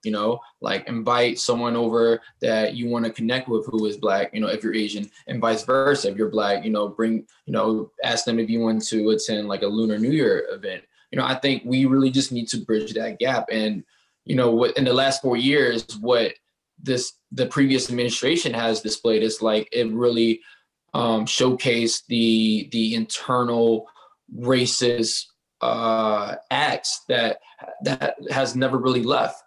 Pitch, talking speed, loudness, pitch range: 115 Hz, 185 wpm, -22 LUFS, 110-125 Hz